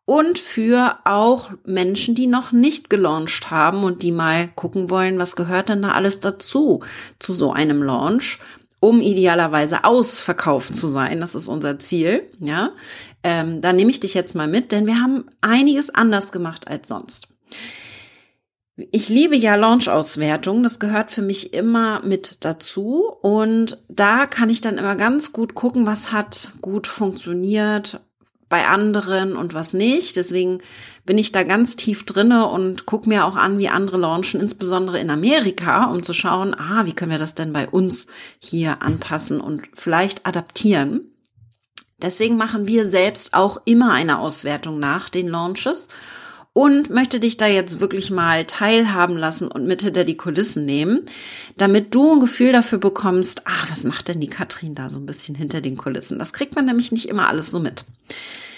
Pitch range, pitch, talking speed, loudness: 175-230 Hz, 195 Hz, 170 wpm, -18 LUFS